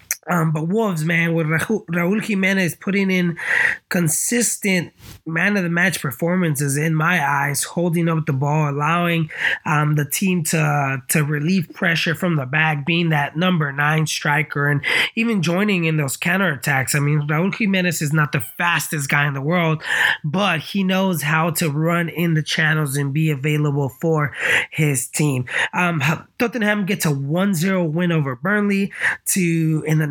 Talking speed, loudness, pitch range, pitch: 165 wpm, -19 LUFS, 150-180 Hz, 165 Hz